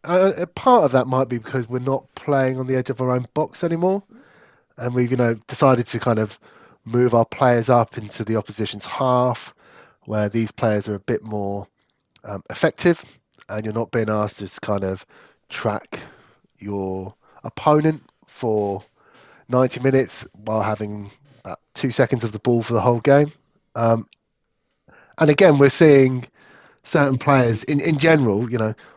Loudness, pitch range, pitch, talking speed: -20 LUFS, 110-140 Hz, 125 Hz, 170 wpm